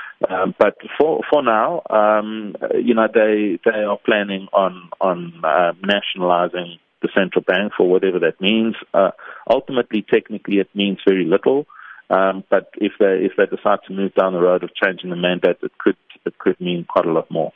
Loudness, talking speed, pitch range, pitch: -18 LUFS, 190 wpm, 90-105 Hz, 95 Hz